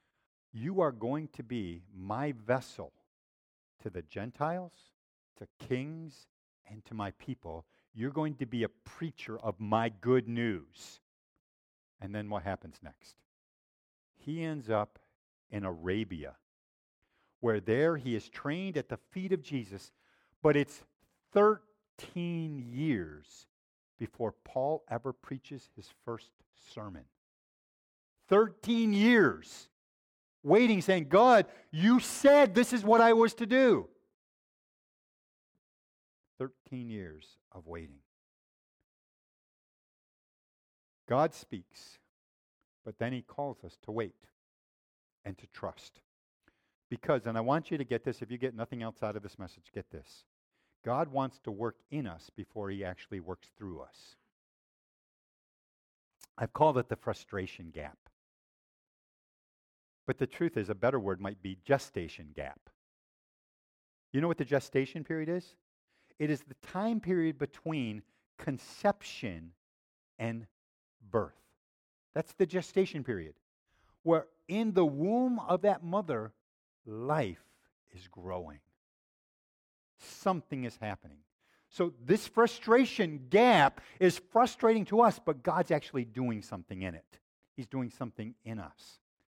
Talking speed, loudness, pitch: 125 wpm, -31 LUFS, 125 Hz